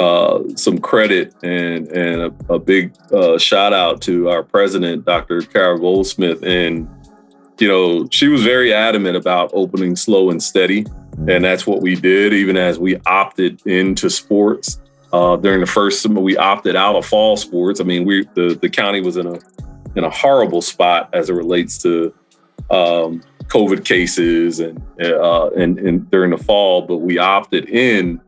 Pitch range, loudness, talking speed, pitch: 85-95 Hz, -15 LUFS, 175 wpm, 90 Hz